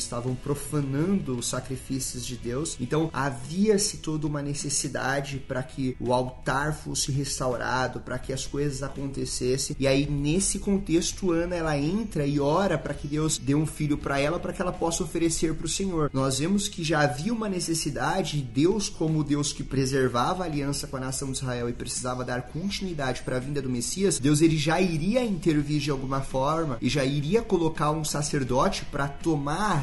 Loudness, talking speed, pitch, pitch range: -27 LUFS, 190 wpm, 145 Hz, 135-165 Hz